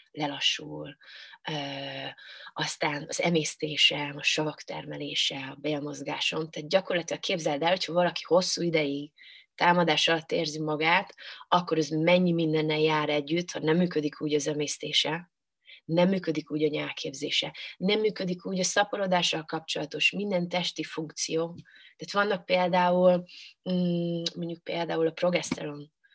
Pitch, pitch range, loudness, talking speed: 160 Hz, 150-180 Hz, -27 LUFS, 125 wpm